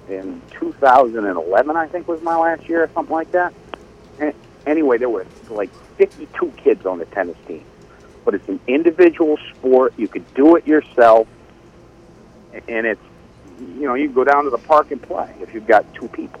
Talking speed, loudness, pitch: 185 wpm, -17 LUFS, 165 Hz